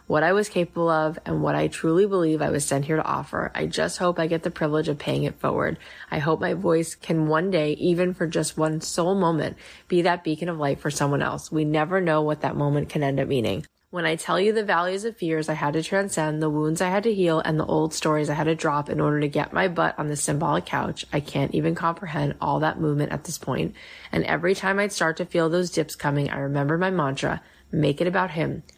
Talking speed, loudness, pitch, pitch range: 255 wpm, -24 LUFS, 160 Hz, 150-175 Hz